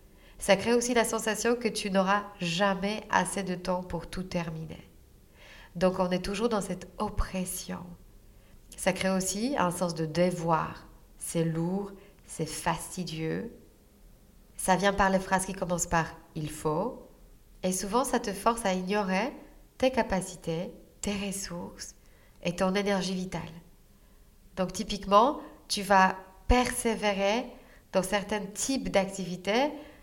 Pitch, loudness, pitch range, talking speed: 190 Hz, -29 LUFS, 175-205 Hz, 135 wpm